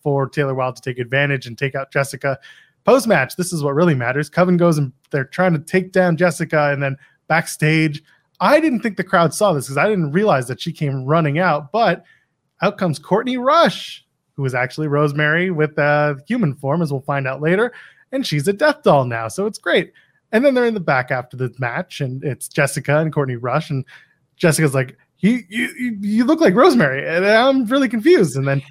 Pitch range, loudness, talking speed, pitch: 140-190 Hz, -18 LUFS, 215 wpm, 155 Hz